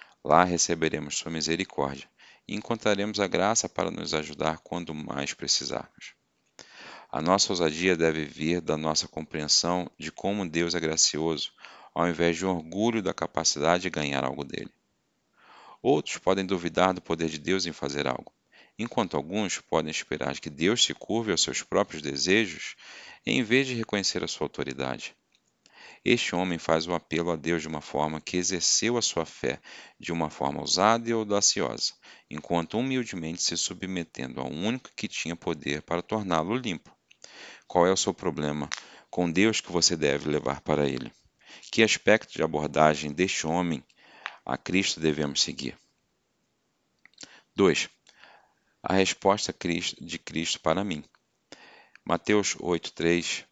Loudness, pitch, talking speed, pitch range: -27 LUFS, 85 Hz, 150 wpm, 75-95 Hz